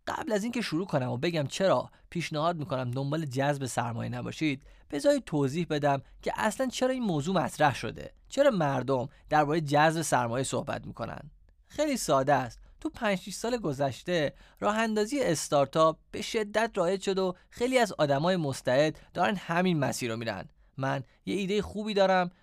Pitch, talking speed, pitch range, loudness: 160 Hz, 160 wpm, 135-200 Hz, -29 LUFS